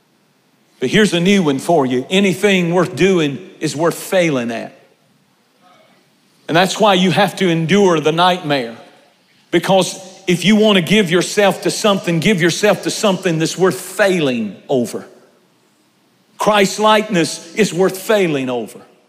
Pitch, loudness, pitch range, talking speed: 185 Hz, -15 LUFS, 165-200 Hz, 145 wpm